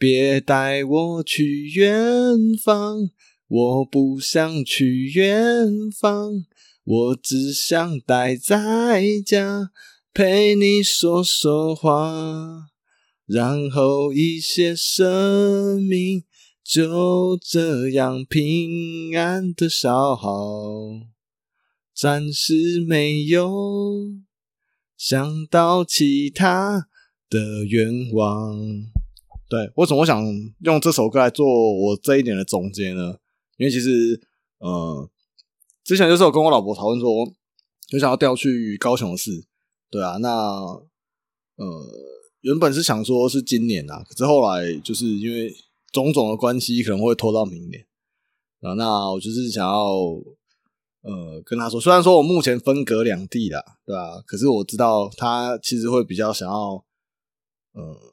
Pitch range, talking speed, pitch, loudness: 115-175 Hz, 170 characters per minute, 140 Hz, -19 LUFS